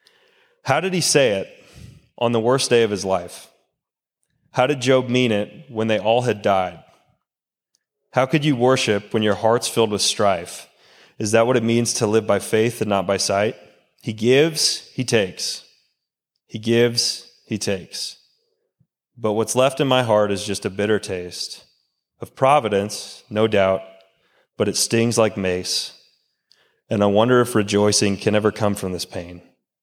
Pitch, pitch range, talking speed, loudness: 110 Hz, 100-125 Hz, 170 wpm, -20 LUFS